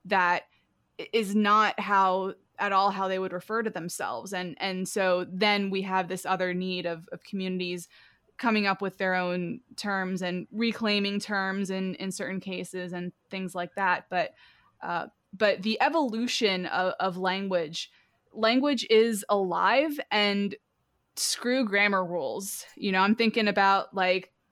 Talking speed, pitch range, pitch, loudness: 150 wpm, 185-210 Hz, 195 Hz, -27 LUFS